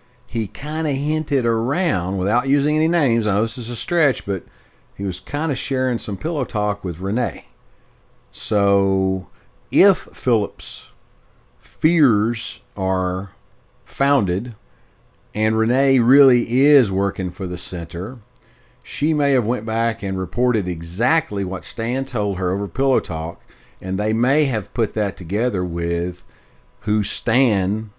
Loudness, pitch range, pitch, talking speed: -20 LUFS, 95-130 Hz, 110 Hz, 135 wpm